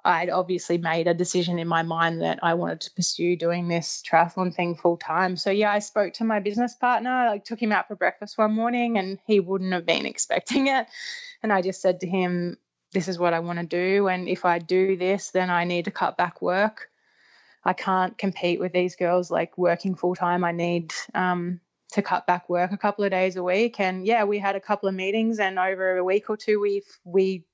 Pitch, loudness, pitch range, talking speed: 185 Hz, -24 LUFS, 175-205 Hz, 235 wpm